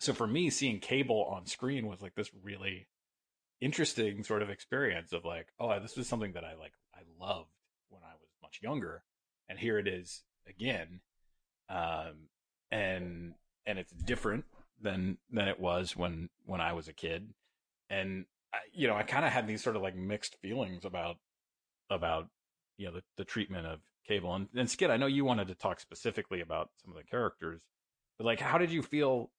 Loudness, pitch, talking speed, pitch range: -36 LUFS, 95 Hz, 195 wpm, 90-110 Hz